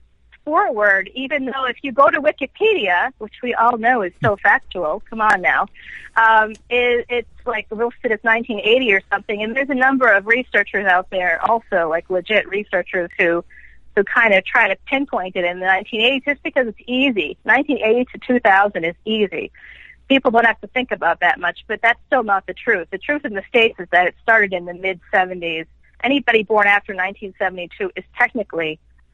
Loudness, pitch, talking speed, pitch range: -17 LUFS, 215 Hz, 190 wpm, 190-245 Hz